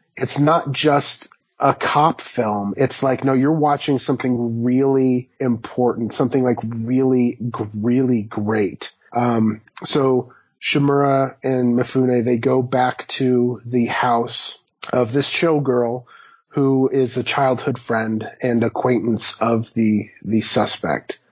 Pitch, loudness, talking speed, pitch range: 125 Hz, -19 LUFS, 125 wpm, 115-135 Hz